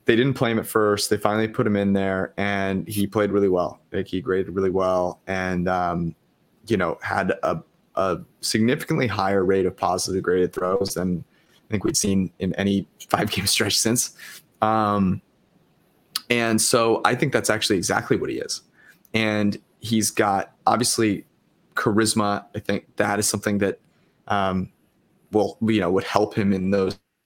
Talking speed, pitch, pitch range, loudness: 170 wpm, 100 Hz, 95-110 Hz, -23 LUFS